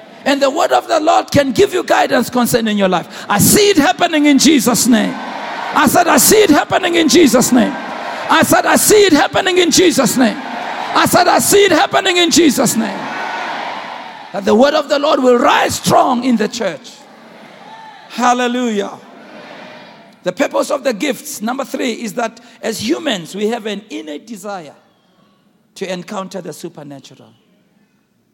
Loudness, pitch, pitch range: -13 LUFS, 245 Hz, 210-300 Hz